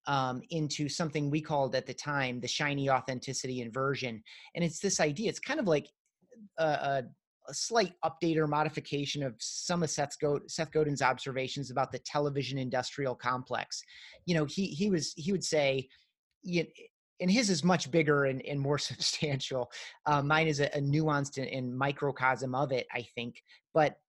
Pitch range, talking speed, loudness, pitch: 130-160 Hz, 175 wpm, -32 LUFS, 145 Hz